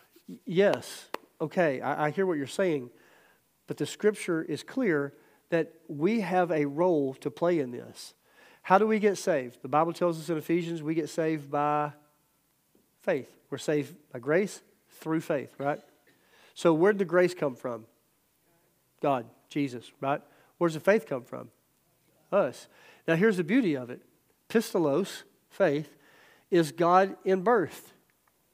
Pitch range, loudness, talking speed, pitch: 145-185 Hz, -29 LUFS, 150 wpm, 165 Hz